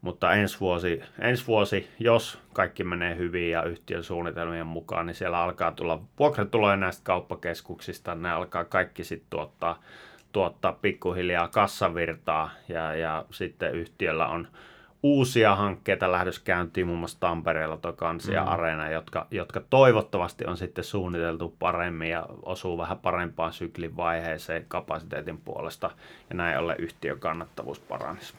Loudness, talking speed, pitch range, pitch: -28 LUFS, 135 wpm, 85-95 Hz, 85 Hz